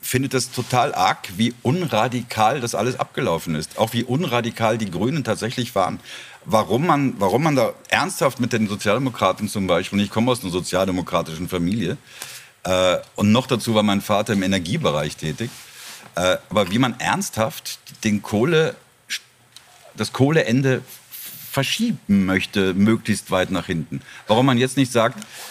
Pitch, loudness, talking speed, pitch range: 110 Hz, -21 LUFS, 155 wpm, 95-125 Hz